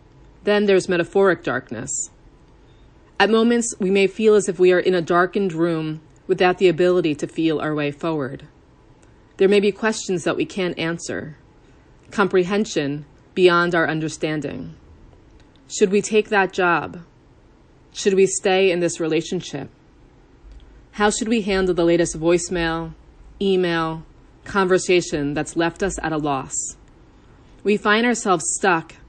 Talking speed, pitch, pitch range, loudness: 140 wpm, 175 Hz, 155-195 Hz, -20 LUFS